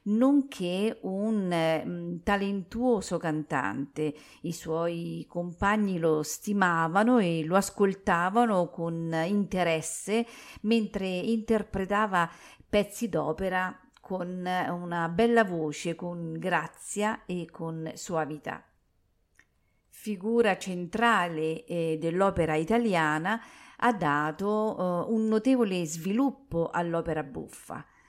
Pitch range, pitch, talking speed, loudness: 165-210 Hz, 180 Hz, 90 wpm, -28 LUFS